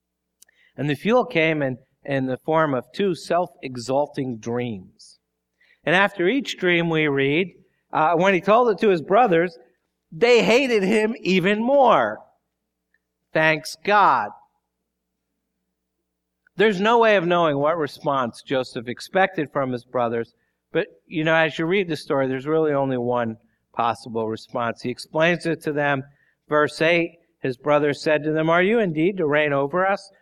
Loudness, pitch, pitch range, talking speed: -21 LUFS, 155 Hz, 125-180 Hz, 155 wpm